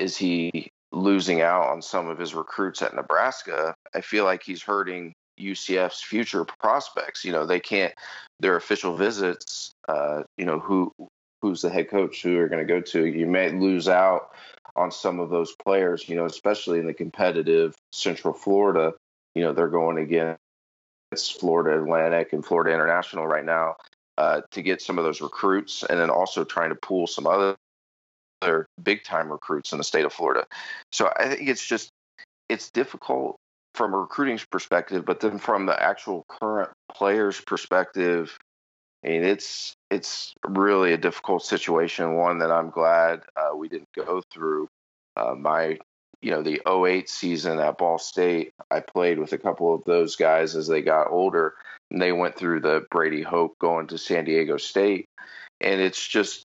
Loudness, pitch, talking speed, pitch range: -24 LUFS, 85 Hz, 175 wpm, 80-95 Hz